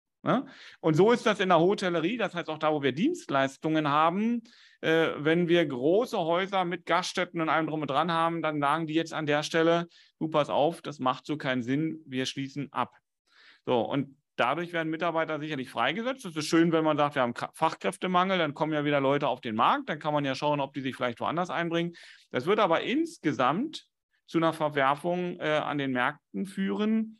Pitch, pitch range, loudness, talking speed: 160 Hz, 145-175 Hz, -28 LUFS, 205 wpm